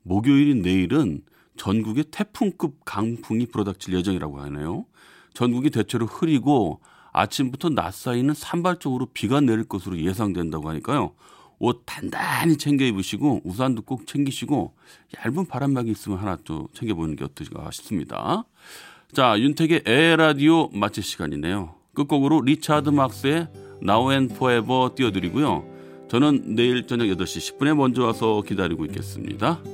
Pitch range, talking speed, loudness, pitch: 100-145 Hz, 350 characters per minute, -23 LUFS, 120 Hz